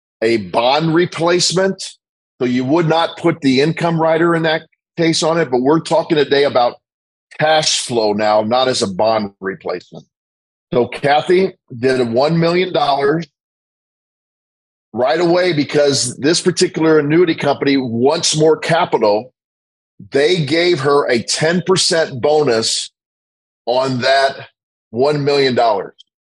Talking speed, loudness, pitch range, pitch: 125 wpm, -15 LUFS, 125-165 Hz, 145 Hz